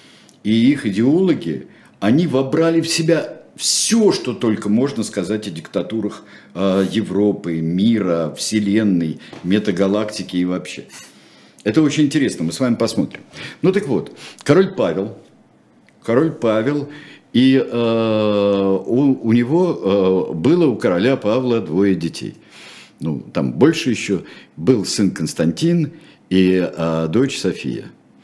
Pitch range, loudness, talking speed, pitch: 95-135 Hz, -18 LUFS, 120 wpm, 110 Hz